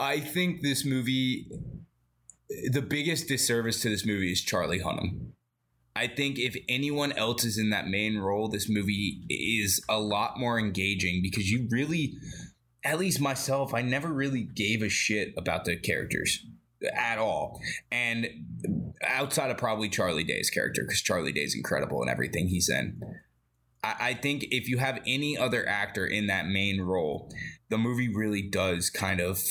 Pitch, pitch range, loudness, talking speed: 115 Hz, 95-130 Hz, -29 LUFS, 165 wpm